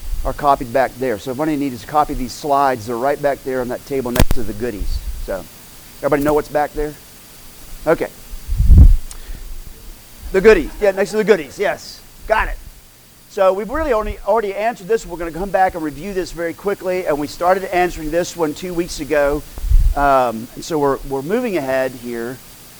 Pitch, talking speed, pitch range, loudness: 145 Hz, 190 wpm, 125-180 Hz, -18 LUFS